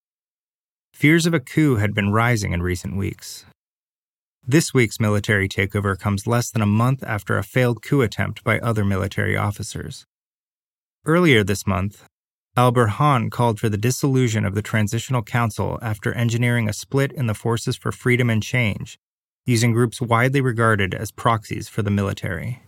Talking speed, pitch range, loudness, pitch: 160 wpm, 105-125 Hz, -20 LUFS, 115 Hz